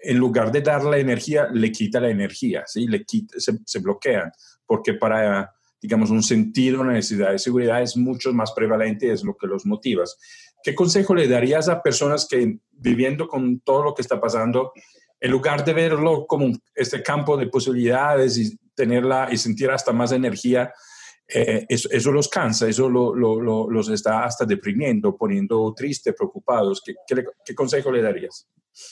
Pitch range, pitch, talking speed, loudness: 115-155 Hz, 125 Hz, 185 wpm, -21 LUFS